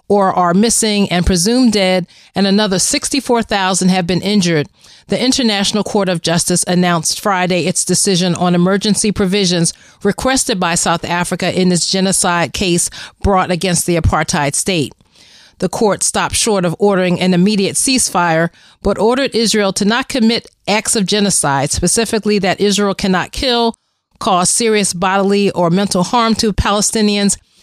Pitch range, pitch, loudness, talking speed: 180-210 Hz, 190 Hz, -14 LUFS, 150 wpm